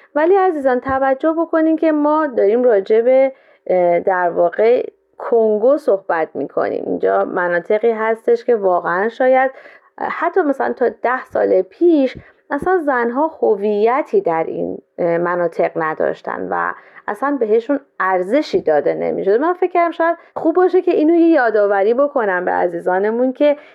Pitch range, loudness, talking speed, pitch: 210-320 Hz, -16 LUFS, 135 wpm, 265 Hz